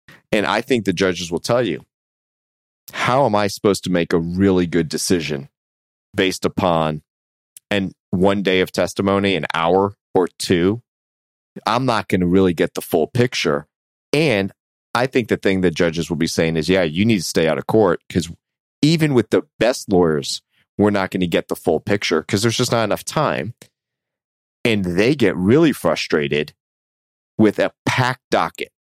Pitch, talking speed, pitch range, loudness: 95 Hz, 175 wpm, 80-100 Hz, -19 LUFS